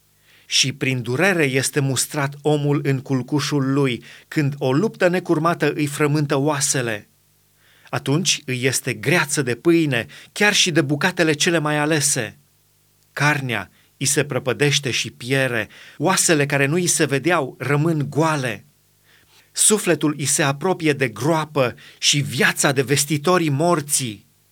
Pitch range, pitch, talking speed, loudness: 135-160 Hz, 145 Hz, 130 wpm, -19 LUFS